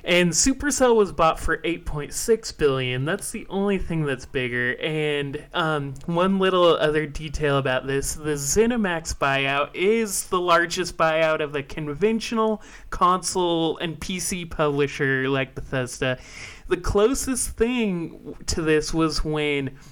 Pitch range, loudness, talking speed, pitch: 145-190 Hz, -23 LUFS, 135 wpm, 160 Hz